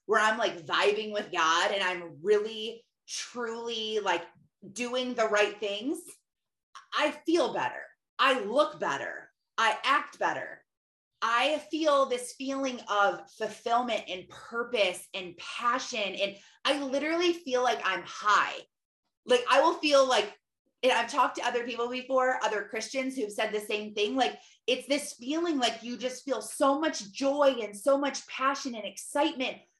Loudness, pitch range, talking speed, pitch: -29 LUFS, 210-275 Hz, 155 wpm, 245 Hz